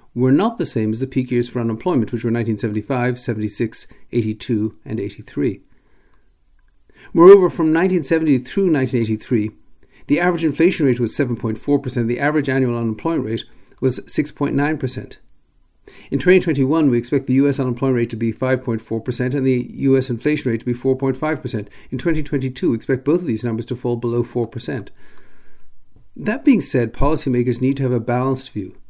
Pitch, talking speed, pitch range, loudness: 125 Hz, 160 wpm, 115-140 Hz, -19 LUFS